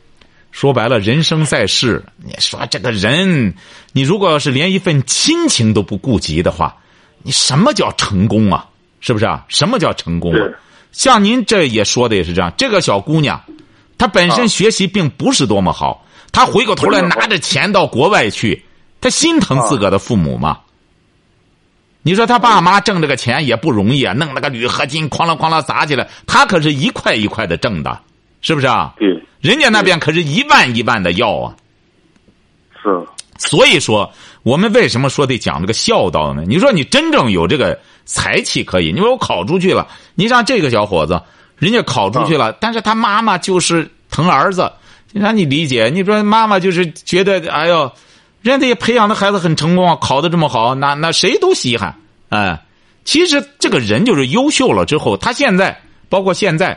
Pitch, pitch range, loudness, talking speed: 170 Hz, 135-215 Hz, -13 LUFS, 275 characters per minute